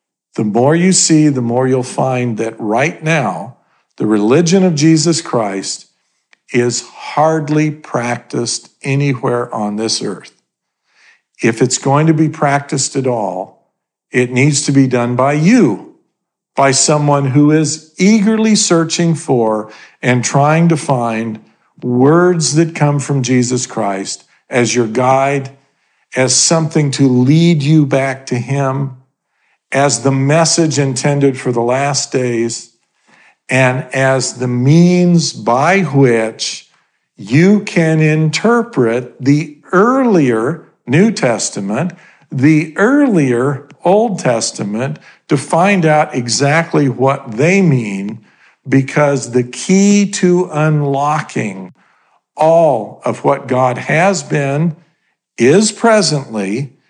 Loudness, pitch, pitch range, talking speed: -13 LUFS, 140 Hz, 125-160 Hz, 115 wpm